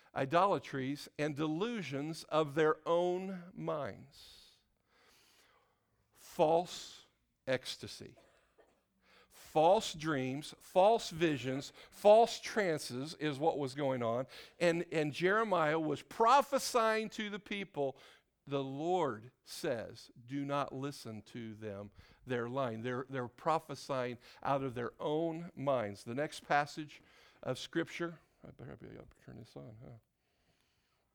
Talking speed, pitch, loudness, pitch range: 115 wpm, 150 Hz, -35 LUFS, 130-170 Hz